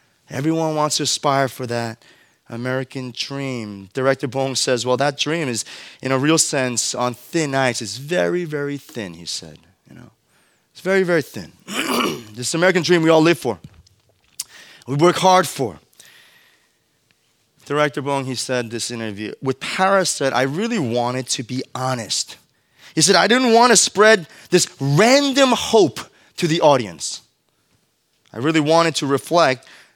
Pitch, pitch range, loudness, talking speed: 135 Hz, 125-165 Hz, -18 LUFS, 160 wpm